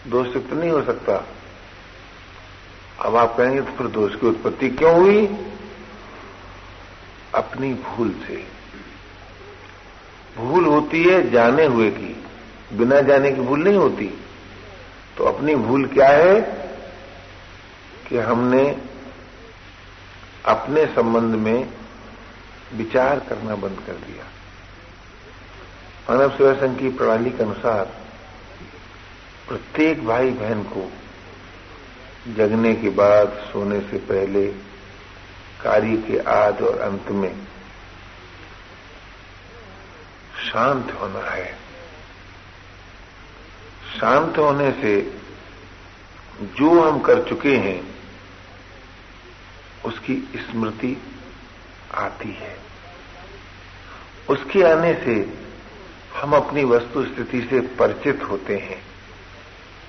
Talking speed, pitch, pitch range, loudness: 95 wpm, 100 Hz, 95-120 Hz, -19 LUFS